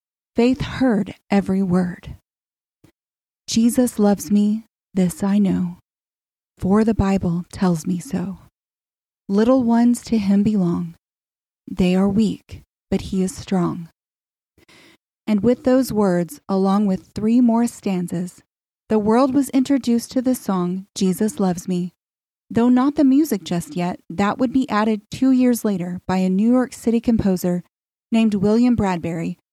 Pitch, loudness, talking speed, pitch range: 205 Hz, -19 LUFS, 140 wpm, 185-235 Hz